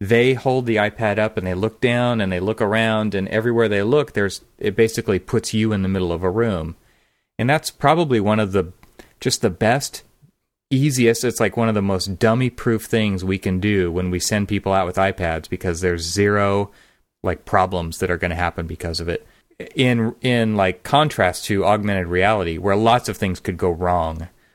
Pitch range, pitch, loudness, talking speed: 90-115 Hz, 105 Hz, -20 LUFS, 205 wpm